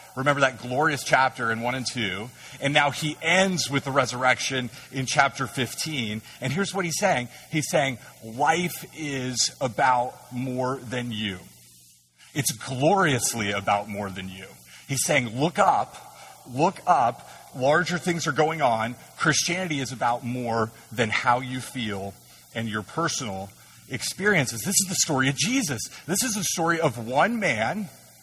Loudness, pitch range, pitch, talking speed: -25 LUFS, 115-160 Hz, 130 Hz, 155 wpm